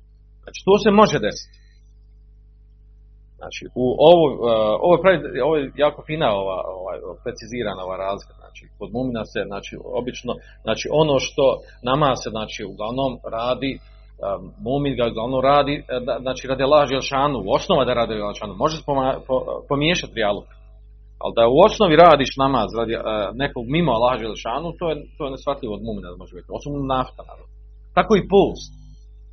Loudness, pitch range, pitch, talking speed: -20 LUFS, 105-145 Hz, 125 Hz, 150 wpm